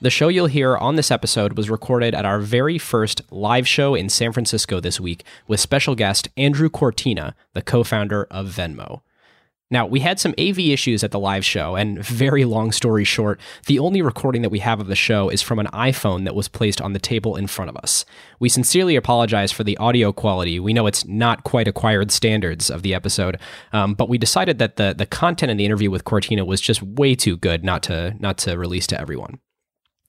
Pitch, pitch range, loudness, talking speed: 110 Hz, 100-125 Hz, -19 LUFS, 220 wpm